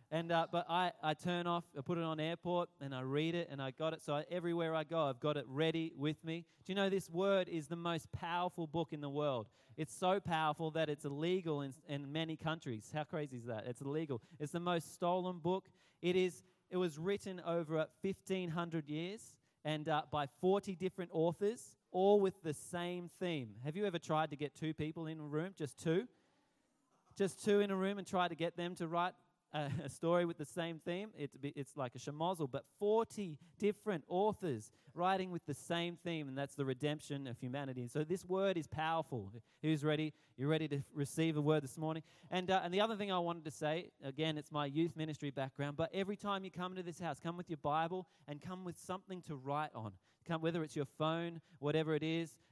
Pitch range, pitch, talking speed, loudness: 150-180 Hz, 160 Hz, 225 wpm, -40 LUFS